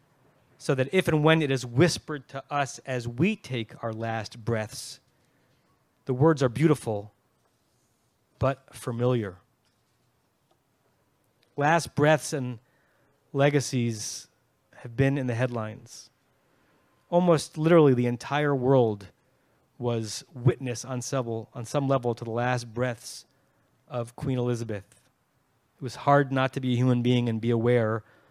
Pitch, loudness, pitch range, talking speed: 130 Hz, -26 LUFS, 120-140 Hz, 130 wpm